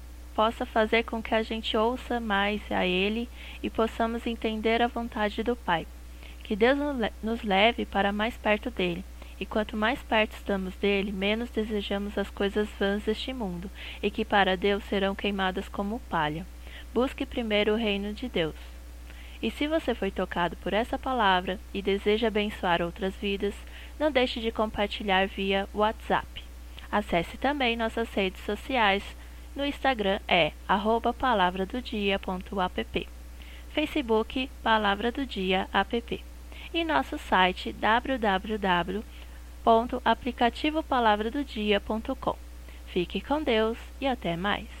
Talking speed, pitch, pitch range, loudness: 130 wpm, 210 Hz, 190-235 Hz, -28 LUFS